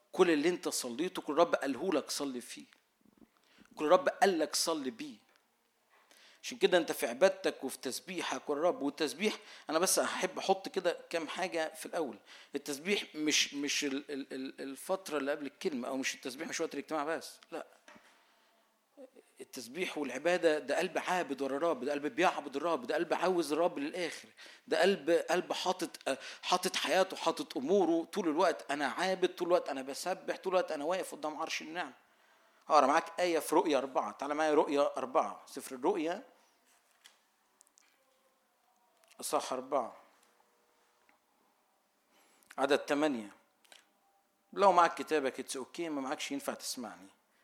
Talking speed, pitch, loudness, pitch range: 145 wpm, 165 Hz, -33 LUFS, 145-190 Hz